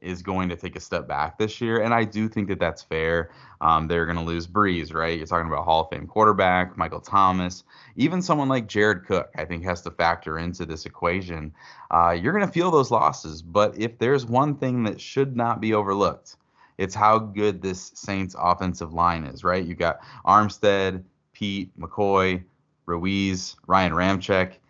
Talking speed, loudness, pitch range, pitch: 190 wpm, -23 LUFS, 85-105 Hz, 95 Hz